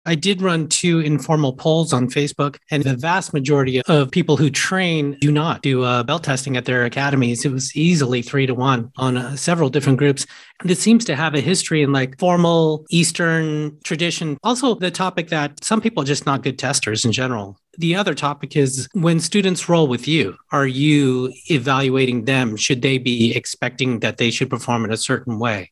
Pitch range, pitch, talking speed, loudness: 130-165 Hz, 145 Hz, 200 wpm, -18 LUFS